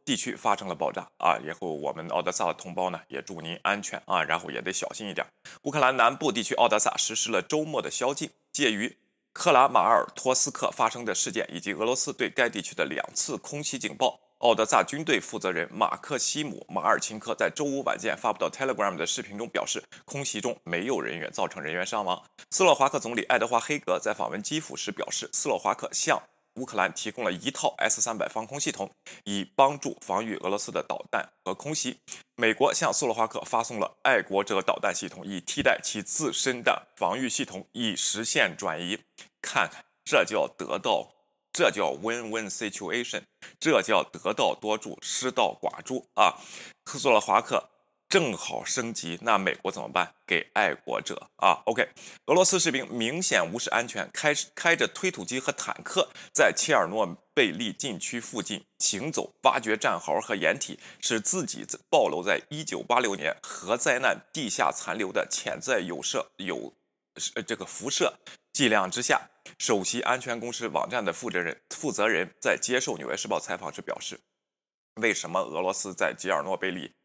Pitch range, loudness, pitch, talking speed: 110-145 Hz, -27 LUFS, 125 Hz, 295 characters per minute